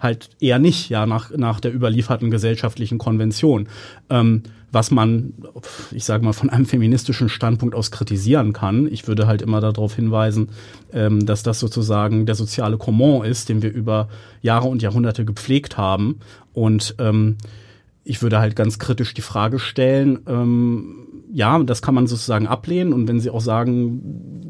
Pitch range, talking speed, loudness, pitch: 110-125 Hz, 165 wpm, -19 LUFS, 115 Hz